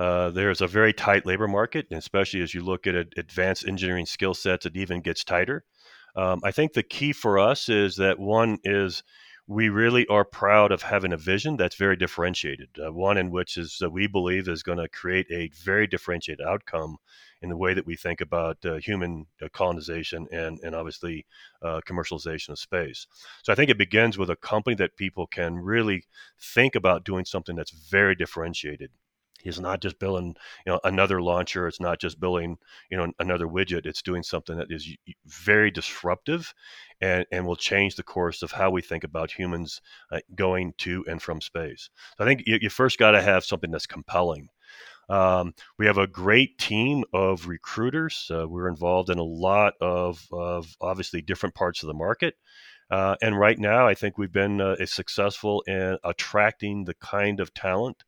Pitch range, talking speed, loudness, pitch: 85-100 Hz, 195 wpm, -25 LUFS, 90 Hz